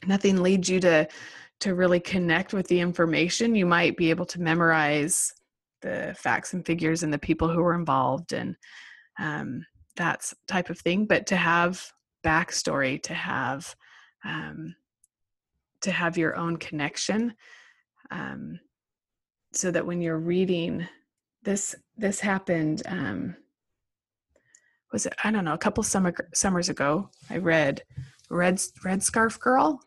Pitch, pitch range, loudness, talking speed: 175 Hz, 165-195 Hz, -26 LUFS, 140 wpm